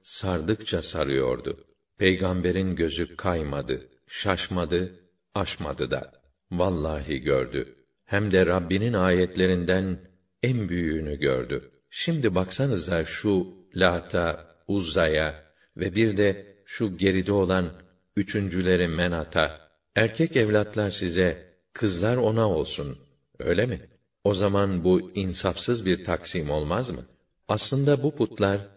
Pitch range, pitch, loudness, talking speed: 90-100 Hz, 95 Hz, -26 LUFS, 100 wpm